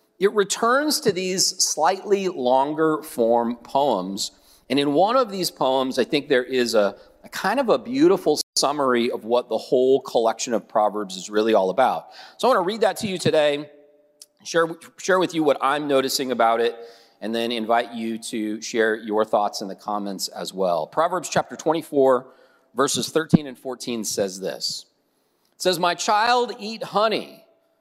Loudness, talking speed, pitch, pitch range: -22 LUFS, 175 wpm, 135 Hz, 115-180 Hz